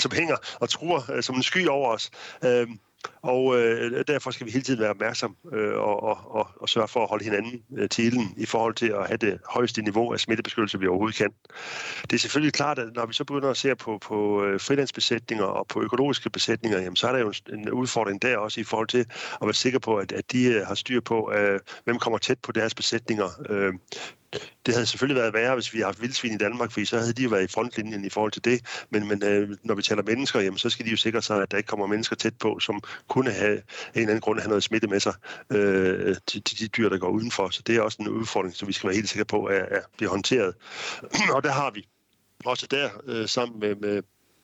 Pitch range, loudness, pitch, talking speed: 105-120 Hz, -26 LUFS, 115 Hz, 240 wpm